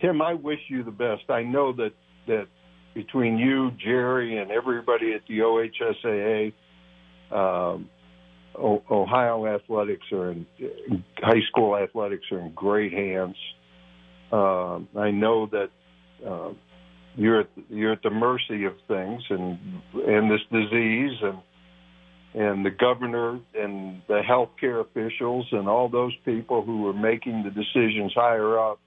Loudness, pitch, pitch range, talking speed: -25 LUFS, 105 Hz, 90-120 Hz, 140 wpm